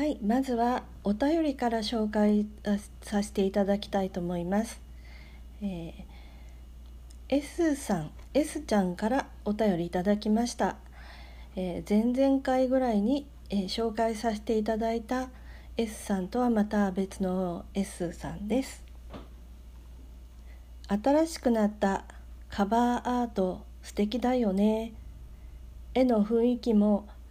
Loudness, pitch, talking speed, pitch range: -29 LUFS, 205 Hz, 230 characters per minute, 165-235 Hz